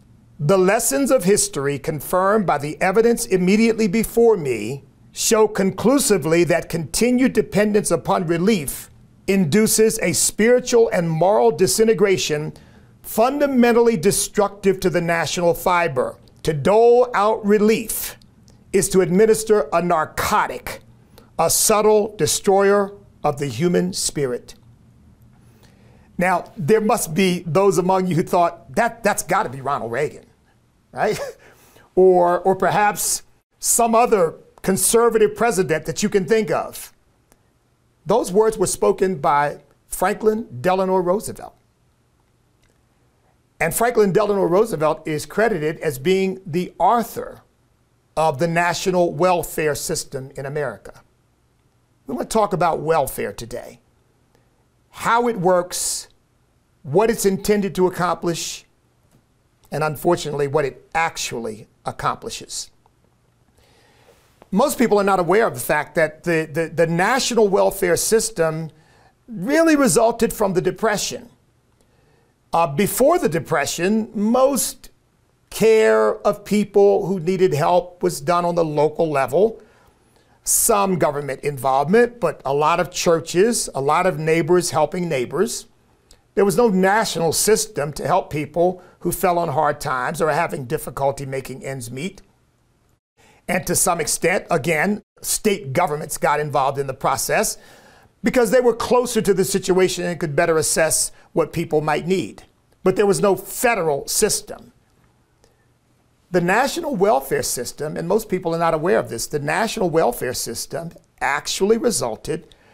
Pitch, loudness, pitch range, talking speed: 185 Hz, -19 LUFS, 155-215 Hz, 130 wpm